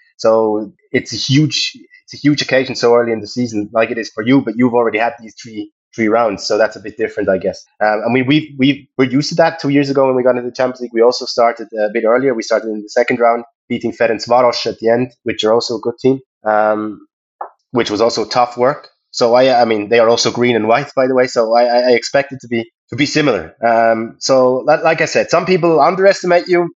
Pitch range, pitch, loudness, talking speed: 115-135 Hz, 120 Hz, -14 LUFS, 260 wpm